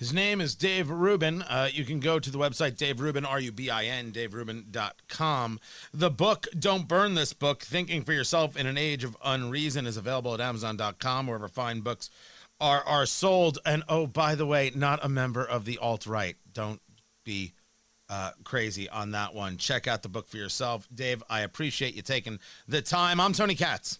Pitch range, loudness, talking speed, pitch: 115-155 Hz, -29 LUFS, 190 wpm, 130 Hz